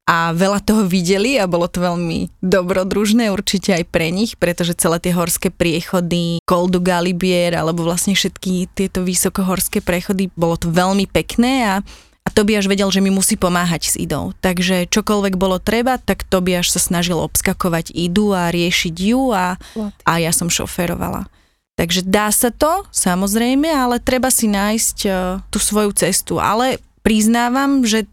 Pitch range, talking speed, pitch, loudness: 175-210 Hz, 165 wpm, 190 Hz, -16 LUFS